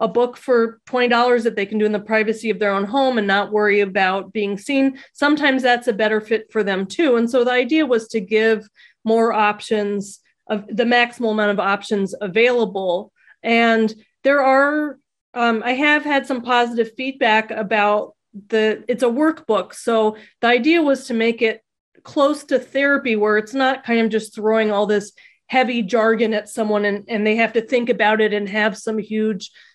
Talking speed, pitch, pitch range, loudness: 190 wpm, 225 Hz, 215-245 Hz, -18 LUFS